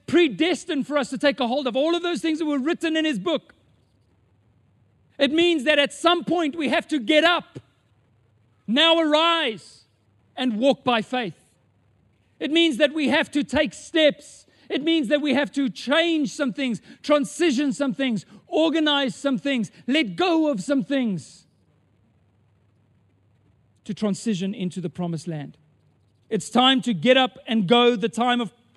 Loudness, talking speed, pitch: -22 LUFS, 165 wpm, 255 Hz